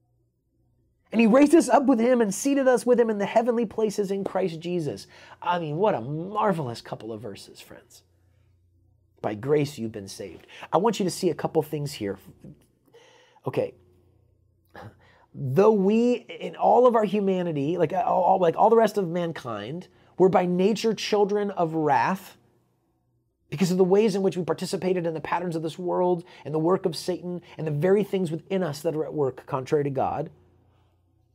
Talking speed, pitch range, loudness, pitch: 185 wpm, 140-205 Hz, -24 LUFS, 175 Hz